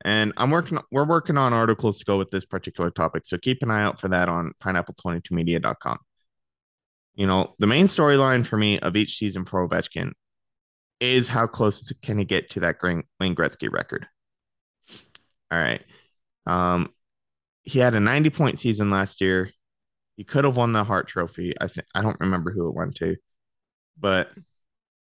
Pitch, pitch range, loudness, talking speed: 100 Hz, 90-120 Hz, -23 LUFS, 175 wpm